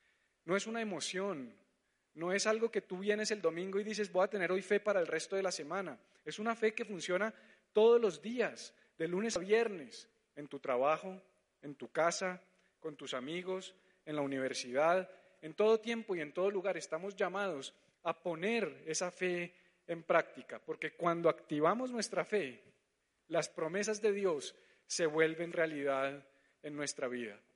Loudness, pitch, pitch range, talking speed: -36 LUFS, 185 Hz, 160-210 Hz, 170 wpm